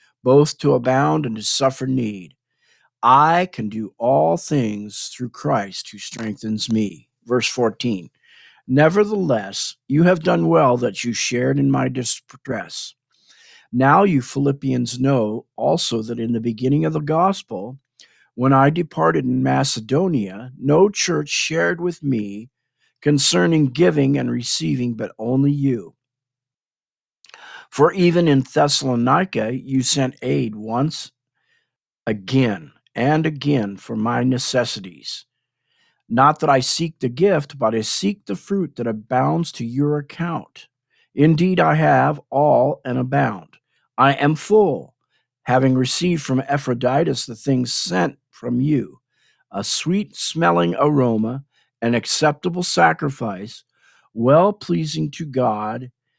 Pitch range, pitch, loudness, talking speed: 120-155 Hz, 130 Hz, -19 LUFS, 125 wpm